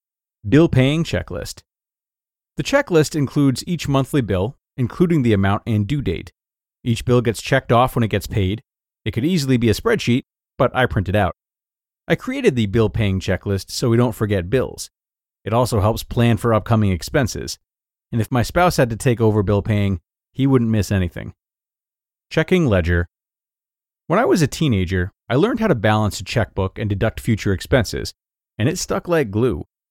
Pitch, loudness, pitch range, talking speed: 115 Hz, -19 LUFS, 100-135 Hz, 180 wpm